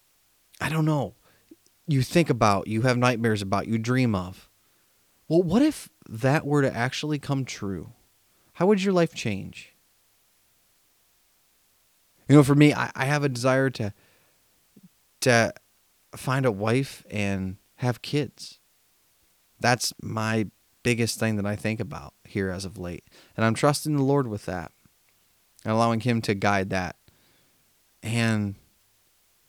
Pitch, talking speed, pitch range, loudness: 115 Hz, 140 wpm, 100-135 Hz, -25 LUFS